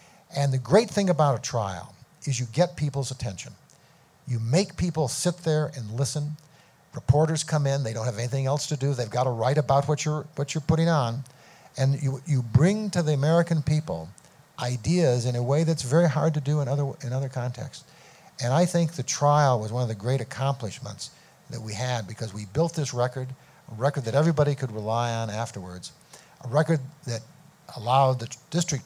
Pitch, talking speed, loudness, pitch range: 140 Hz, 200 wpm, -26 LUFS, 125-155 Hz